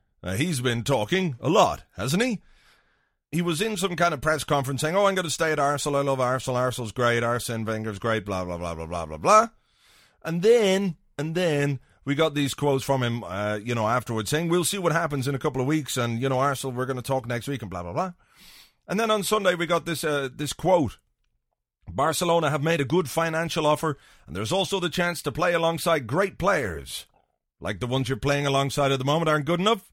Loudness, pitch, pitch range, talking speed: -25 LUFS, 145 Hz, 125-170 Hz, 235 wpm